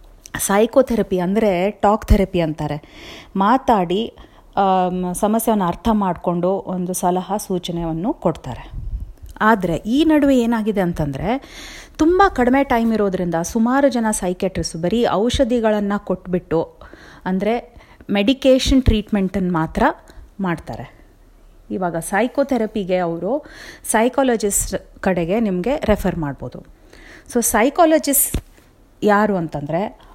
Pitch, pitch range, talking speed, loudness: 200 Hz, 175-235 Hz, 90 wpm, -18 LUFS